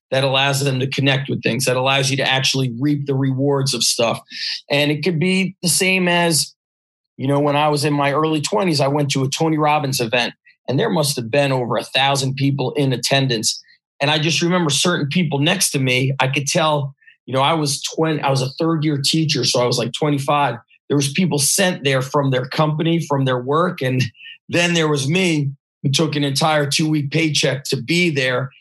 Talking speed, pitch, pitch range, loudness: 220 wpm, 145 Hz, 135-160 Hz, -18 LUFS